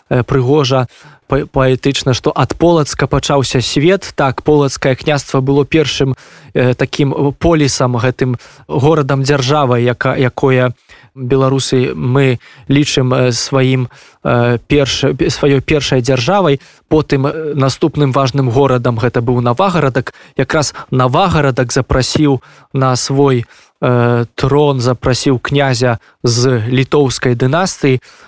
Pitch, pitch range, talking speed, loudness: 135 Hz, 125-145 Hz, 100 wpm, -13 LUFS